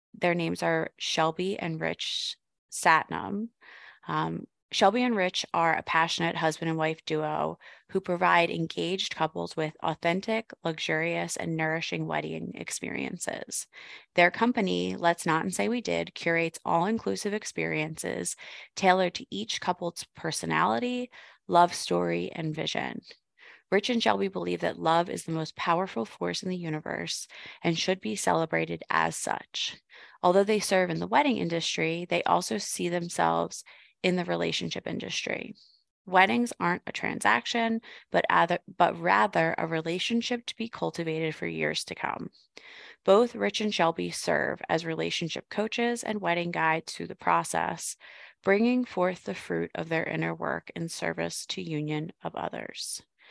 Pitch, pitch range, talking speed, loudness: 165 Hz, 155-195 Hz, 145 wpm, -28 LUFS